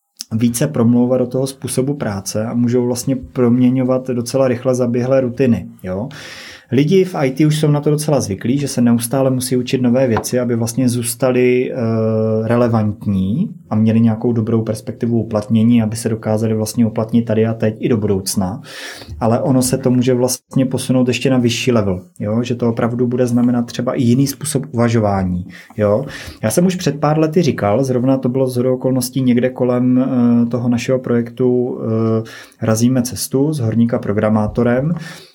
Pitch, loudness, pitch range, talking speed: 125 Hz, -16 LUFS, 115-130 Hz, 165 wpm